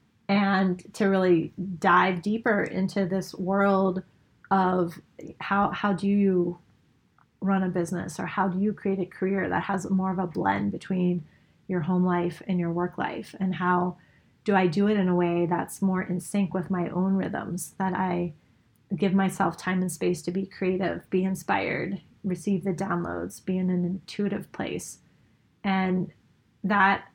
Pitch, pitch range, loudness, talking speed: 185 Hz, 175-195 Hz, -27 LUFS, 170 wpm